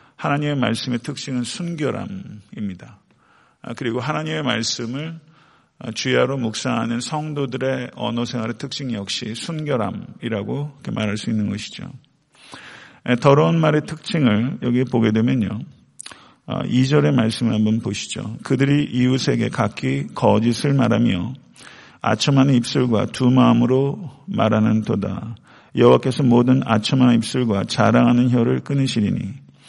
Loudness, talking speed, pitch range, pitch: -20 LUFS, 285 characters per minute, 115-140 Hz, 125 Hz